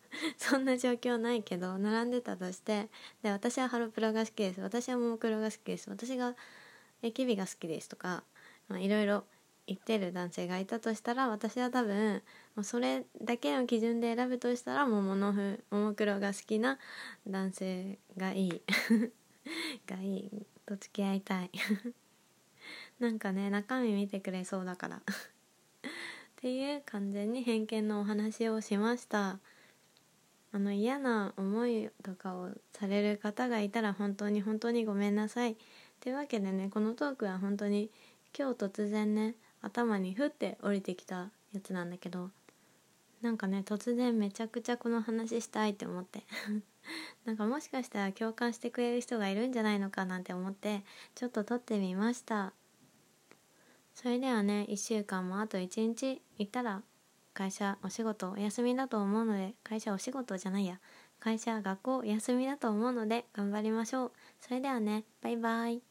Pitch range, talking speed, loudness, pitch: 200-240 Hz, 315 characters per minute, -35 LUFS, 215 Hz